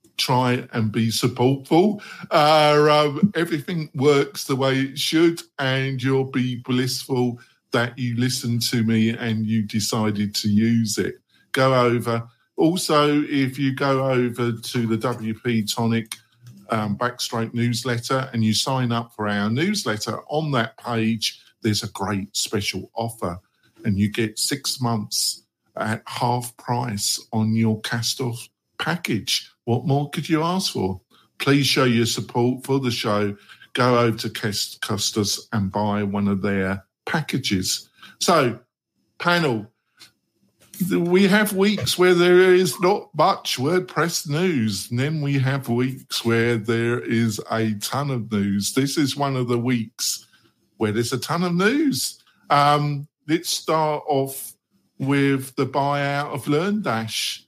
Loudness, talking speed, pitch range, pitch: -22 LUFS, 145 wpm, 115-145 Hz, 125 Hz